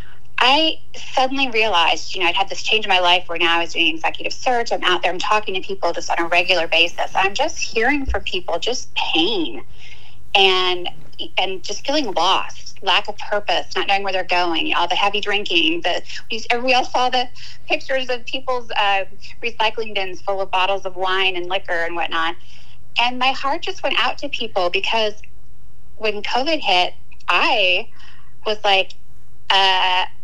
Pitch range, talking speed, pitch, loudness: 185-270 Hz, 180 wpm, 210 Hz, -19 LUFS